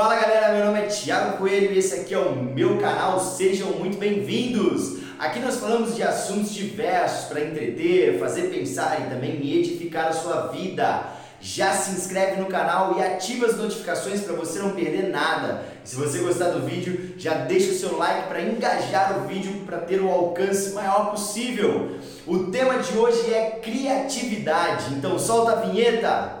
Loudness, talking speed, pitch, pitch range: -23 LUFS, 175 wpm, 195 Hz, 180-225 Hz